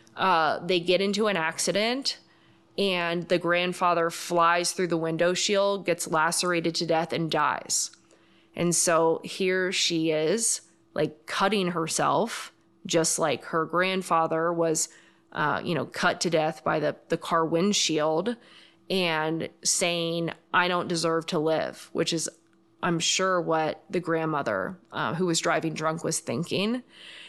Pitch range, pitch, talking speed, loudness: 165-180 Hz, 170 Hz, 145 wpm, -26 LUFS